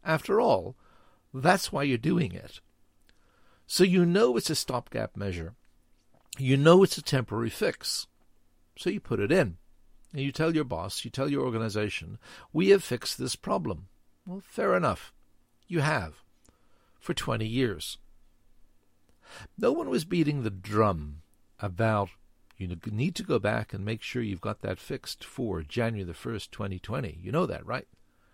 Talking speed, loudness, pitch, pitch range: 160 wpm, -29 LUFS, 105 Hz, 80-135 Hz